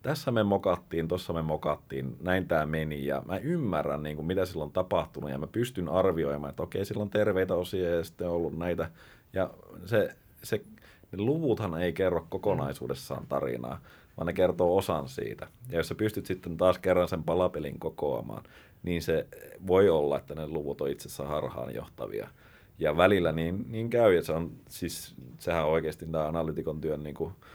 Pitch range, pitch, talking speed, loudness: 75-95 Hz, 85 Hz, 190 wpm, -30 LUFS